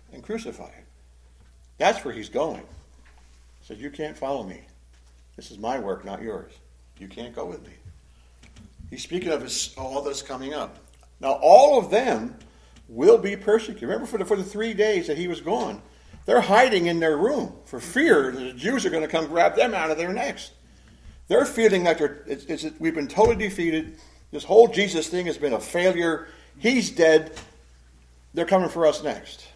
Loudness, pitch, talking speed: -22 LUFS, 150 Hz, 195 wpm